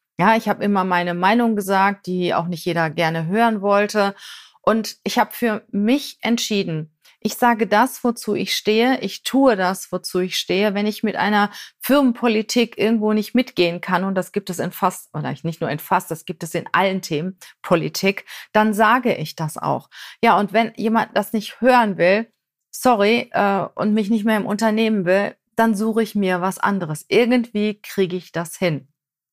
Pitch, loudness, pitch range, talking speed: 205 Hz, -20 LUFS, 180-225 Hz, 190 wpm